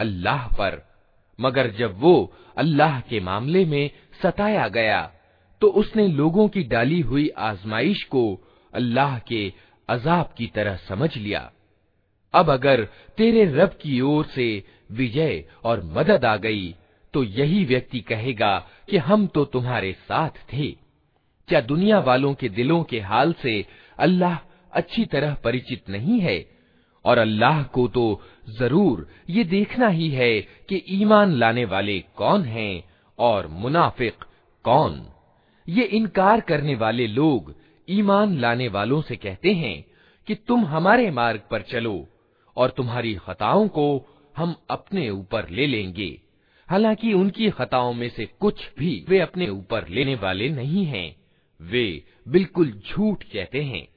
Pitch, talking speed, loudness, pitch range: 135 Hz, 140 wpm, -22 LUFS, 110-180 Hz